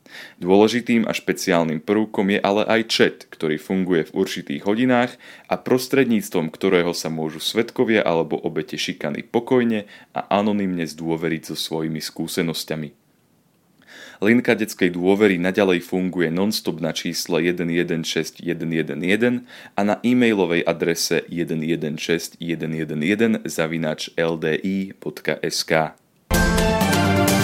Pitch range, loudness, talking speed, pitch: 80-105 Hz, -21 LUFS, 95 wpm, 90 Hz